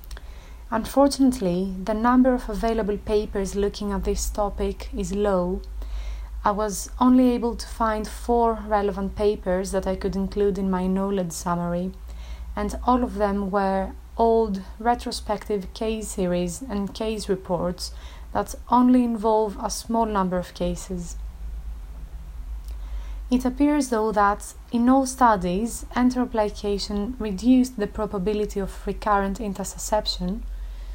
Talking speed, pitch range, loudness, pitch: 120 wpm, 185-225 Hz, -24 LUFS, 205 Hz